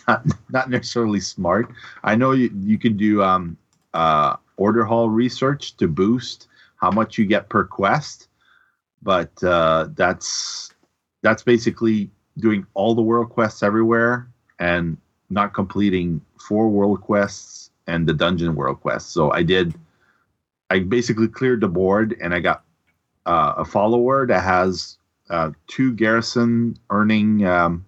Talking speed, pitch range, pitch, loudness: 140 wpm, 95-120 Hz, 110 Hz, -20 LUFS